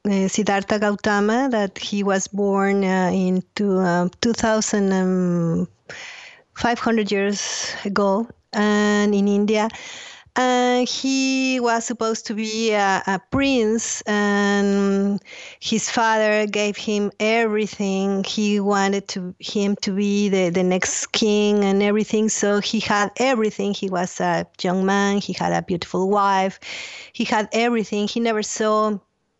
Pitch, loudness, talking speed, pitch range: 205 Hz, -20 LUFS, 130 wpm, 195-220 Hz